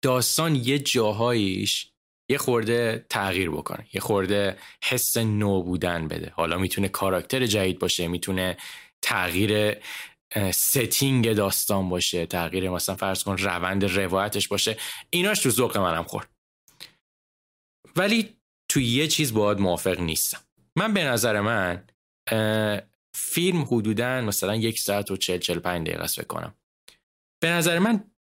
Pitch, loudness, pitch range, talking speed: 105 Hz, -24 LUFS, 95-125 Hz, 125 wpm